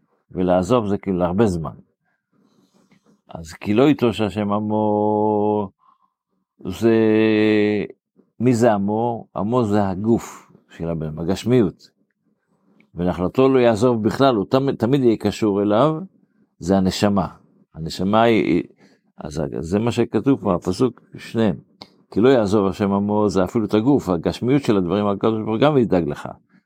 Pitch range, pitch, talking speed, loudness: 95-120 Hz, 105 Hz, 135 wpm, -19 LUFS